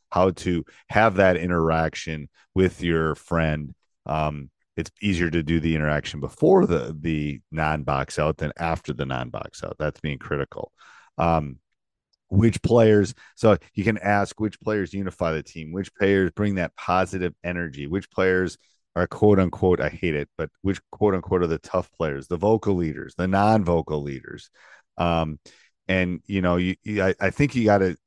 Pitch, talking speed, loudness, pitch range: 90 Hz, 175 wpm, -24 LUFS, 80-100 Hz